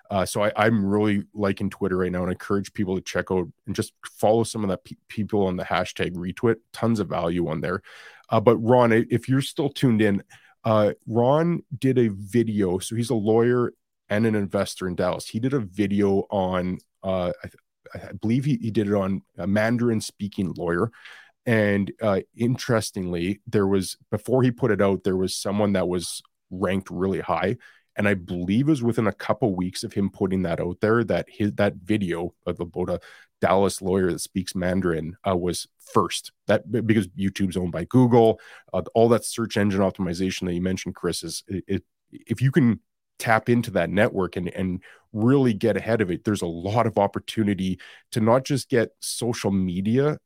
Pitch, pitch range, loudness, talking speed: 100 Hz, 95-115 Hz, -24 LUFS, 200 wpm